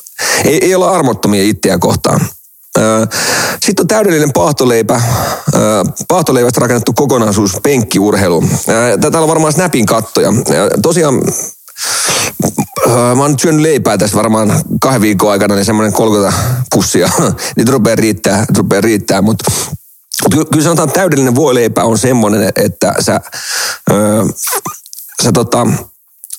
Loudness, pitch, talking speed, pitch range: -10 LUFS, 120 Hz, 120 wpm, 105-150 Hz